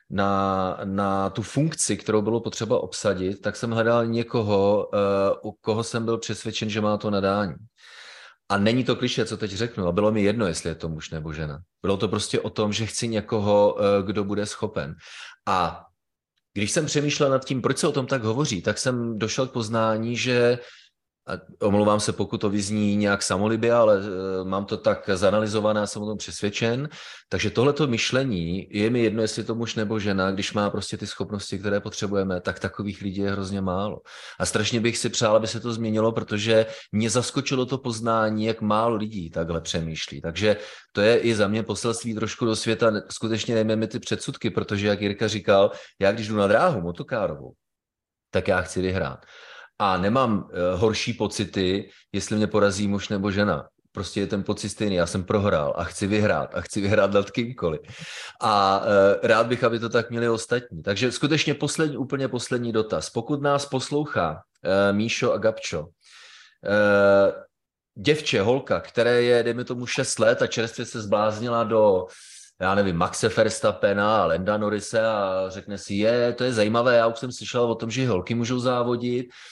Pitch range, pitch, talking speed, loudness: 100-115 Hz, 110 Hz, 185 wpm, -24 LUFS